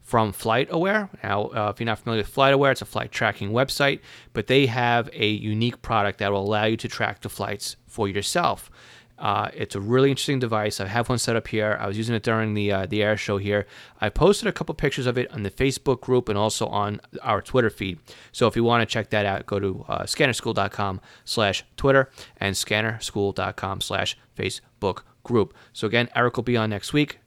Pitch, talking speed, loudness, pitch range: 110 Hz, 215 wpm, -24 LUFS, 105-125 Hz